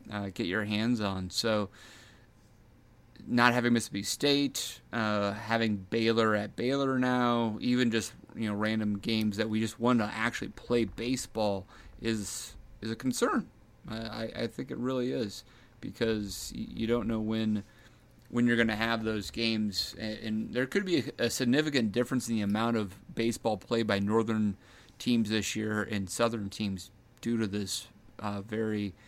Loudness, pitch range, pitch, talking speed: -31 LUFS, 105-120 Hz, 110 Hz, 160 wpm